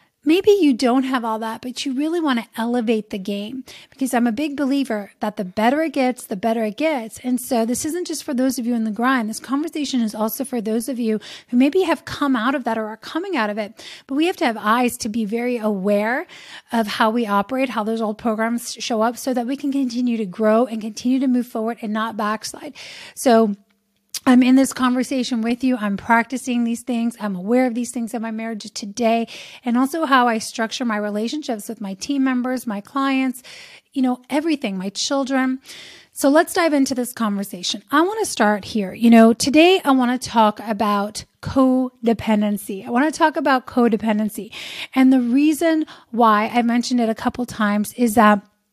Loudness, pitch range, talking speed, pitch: -20 LUFS, 220-270 Hz, 210 wpm, 240 Hz